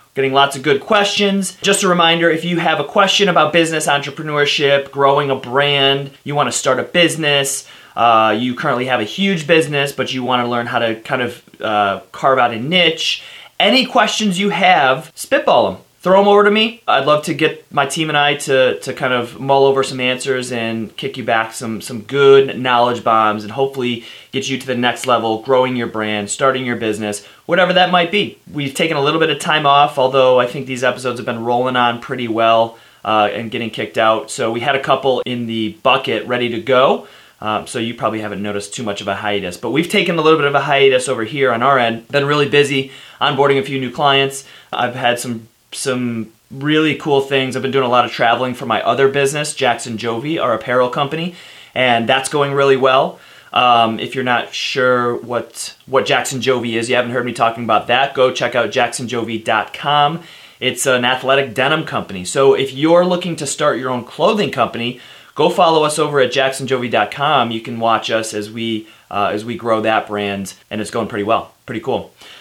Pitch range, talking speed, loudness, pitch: 115-145 Hz, 215 wpm, -15 LUFS, 130 Hz